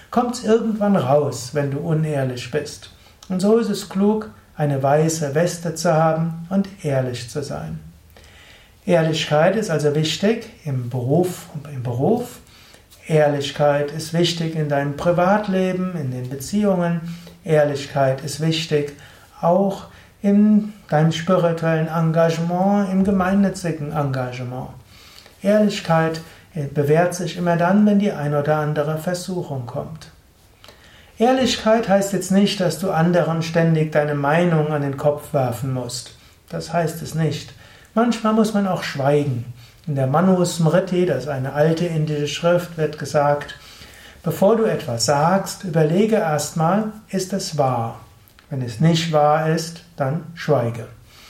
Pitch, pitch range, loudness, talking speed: 160 Hz, 140-185 Hz, -20 LUFS, 135 wpm